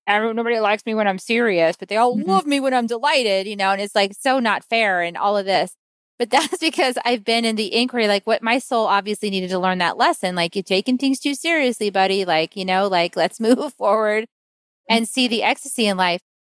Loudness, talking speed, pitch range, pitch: -19 LUFS, 235 wpm, 195-245 Hz, 220 Hz